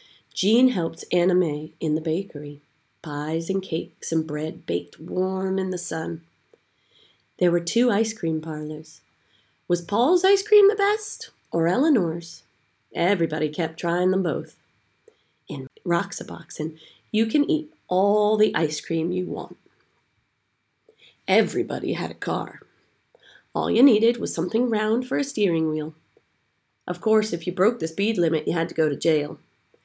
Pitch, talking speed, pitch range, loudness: 170 Hz, 150 wpm, 155-215 Hz, -24 LUFS